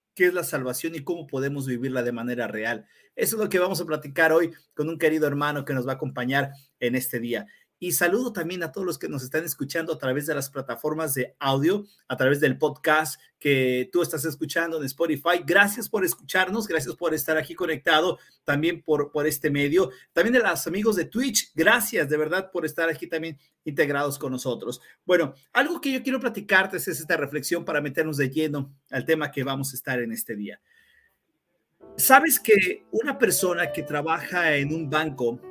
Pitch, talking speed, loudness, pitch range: 160 Hz, 200 wpm, -24 LUFS, 140-180 Hz